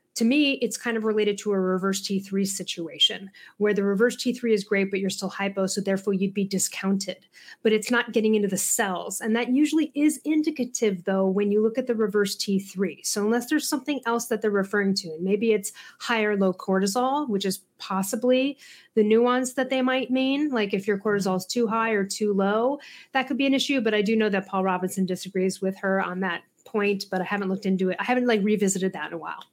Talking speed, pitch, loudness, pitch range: 230 wpm, 210 Hz, -25 LUFS, 195-240 Hz